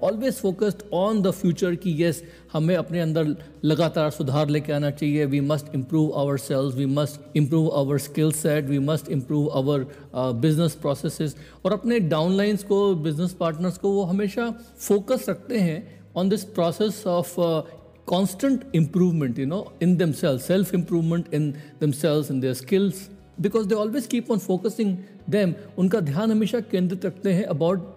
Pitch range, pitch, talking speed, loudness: 150-195 Hz, 170 Hz, 165 wpm, -24 LUFS